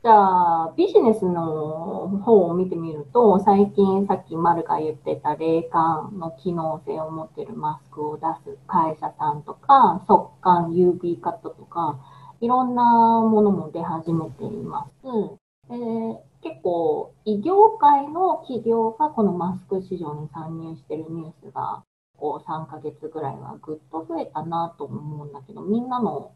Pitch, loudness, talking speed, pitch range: 180 Hz, -22 LUFS, 300 characters per minute, 160-225 Hz